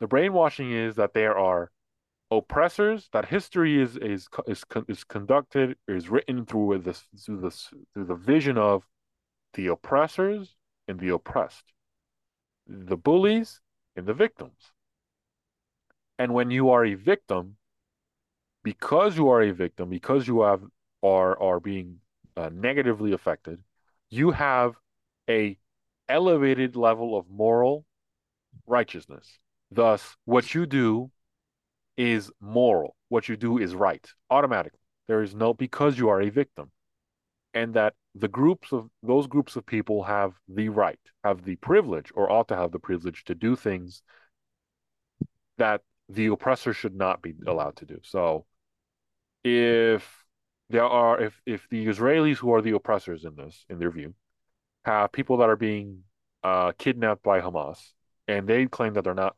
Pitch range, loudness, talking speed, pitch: 95-125 Hz, -25 LUFS, 150 wpm, 110 Hz